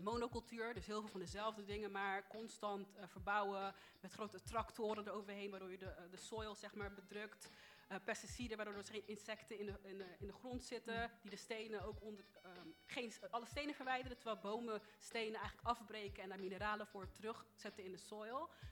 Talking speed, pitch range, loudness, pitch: 195 wpm, 200-225 Hz, -48 LUFS, 210 Hz